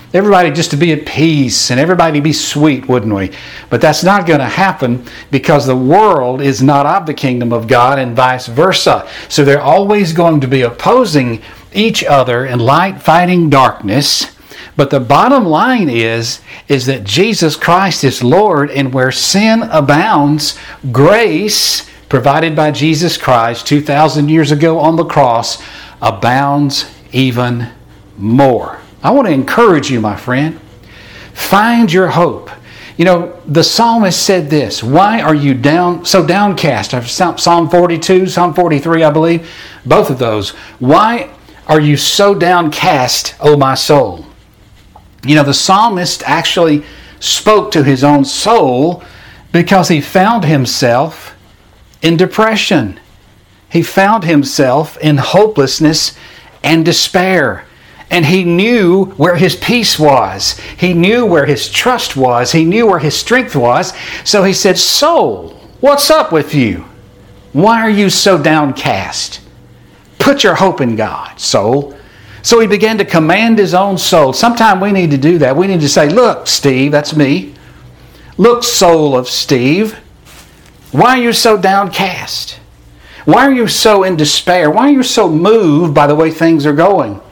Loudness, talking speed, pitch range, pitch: -10 LUFS, 150 wpm, 130-185 Hz, 150 Hz